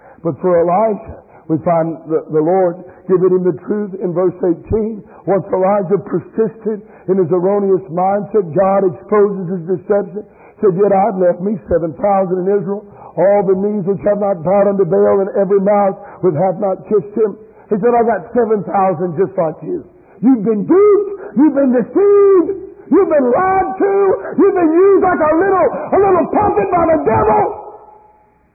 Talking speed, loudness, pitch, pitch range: 175 wpm, -14 LUFS, 205 Hz, 190-290 Hz